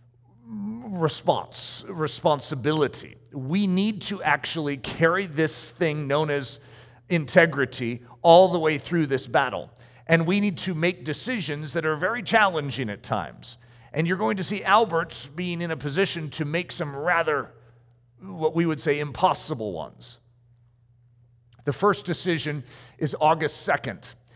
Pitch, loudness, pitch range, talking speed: 155 Hz, -24 LUFS, 125-175 Hz, 140 wpm